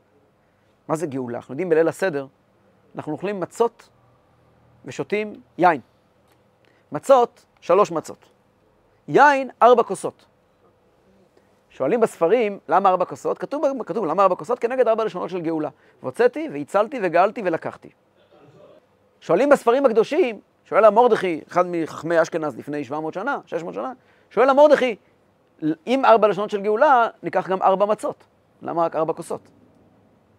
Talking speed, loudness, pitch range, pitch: 130 wpm, -20 LUFS, 155-235 Hz, 190 Hz